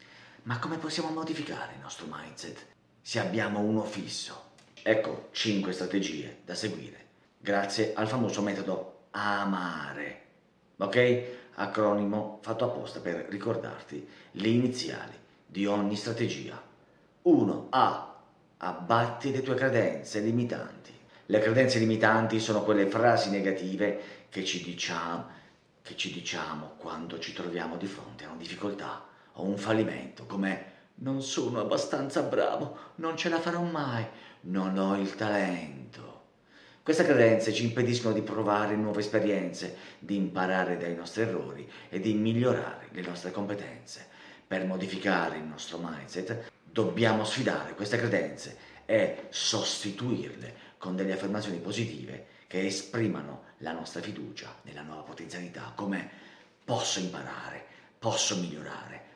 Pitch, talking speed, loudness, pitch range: 105 Hz, 125 wpm, -31 LUFS, 95-115 Hz